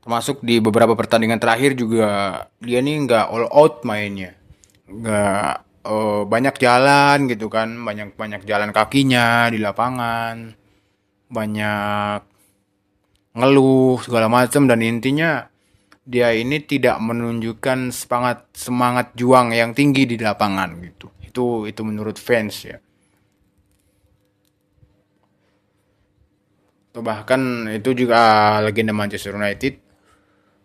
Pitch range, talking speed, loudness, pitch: 100-120 Hz, 105 wpm, -18 LUFS, 110 Hz